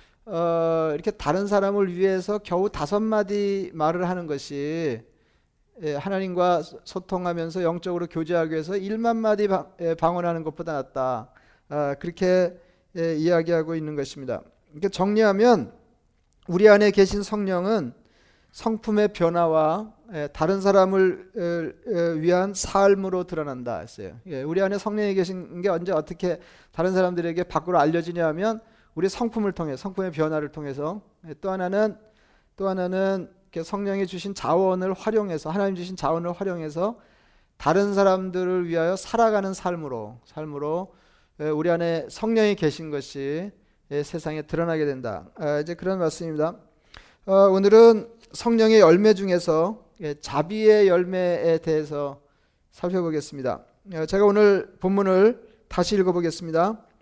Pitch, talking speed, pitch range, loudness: 180 Hz, 305 characters per minute, 160-200 Hz, -23 LUFS